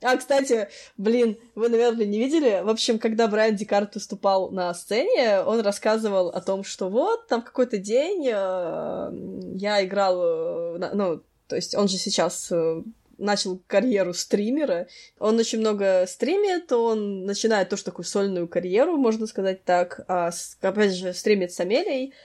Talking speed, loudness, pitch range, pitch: 150 wpm, -24 LUFS, 190-235 Hz, 210 Hz